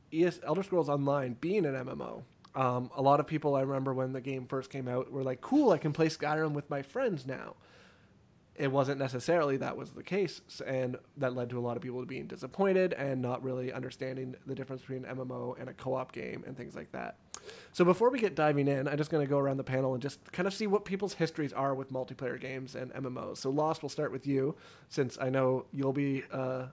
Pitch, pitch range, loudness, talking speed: 135 Hz, 130-155 Hz, -33 LUFS, 235 wpm